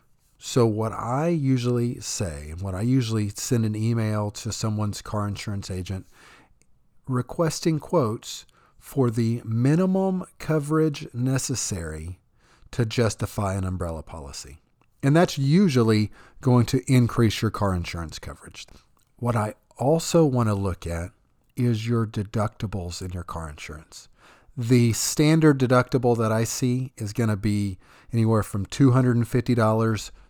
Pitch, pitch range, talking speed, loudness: 115 Hz, 100-130 Hz, 130 wpm, -24 LUFS